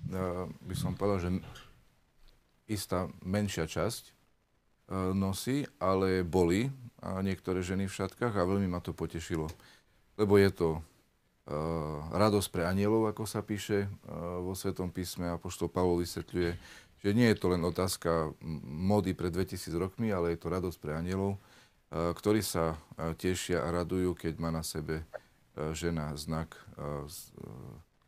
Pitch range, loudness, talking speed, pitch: 85-100 Hz, -33 LUFS, 150 wpm, 90 Hz